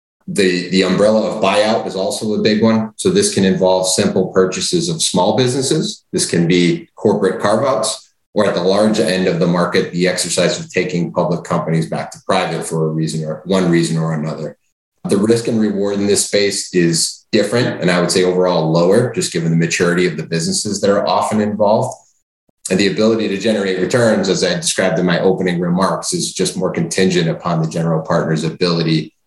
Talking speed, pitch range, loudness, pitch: 200 wpm, 85-105 Hz, -15 LUFS, 90 Hz